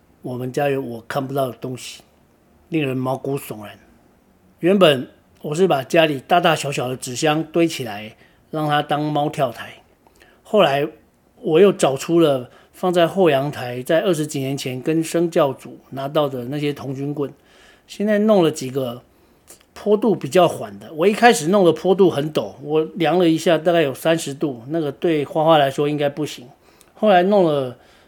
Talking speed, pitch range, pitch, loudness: 250 characters per minute, 135-170 Hz, 150 Hz, -19 LUFS